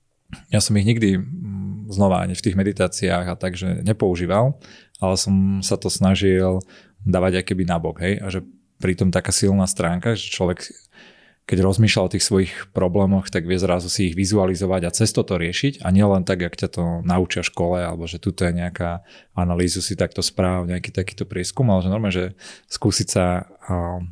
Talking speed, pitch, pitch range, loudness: 180 wpm, 95 Hz, 90-100 Hz, -21 LUFS